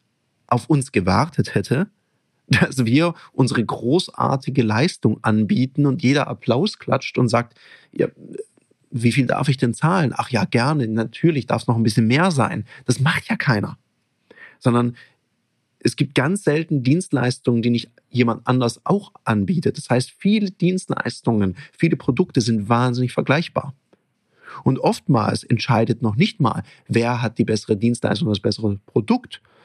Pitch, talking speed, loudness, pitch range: 125 Hz, 150 wpm, -20 LUFS, 120-150 Hz